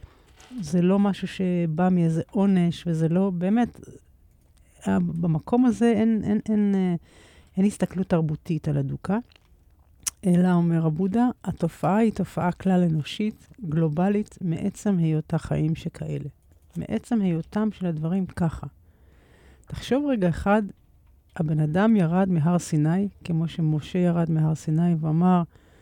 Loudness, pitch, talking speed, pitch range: -24 LUFS, 175 Hz, 120 wpm, 160-195 Hz